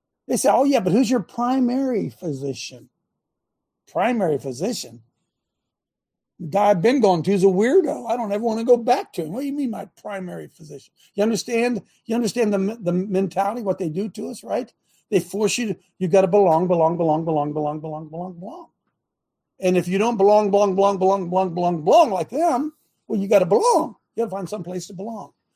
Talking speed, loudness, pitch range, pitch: 200 wpm, -21 LUFS, 180-230 Hz, 200 Hz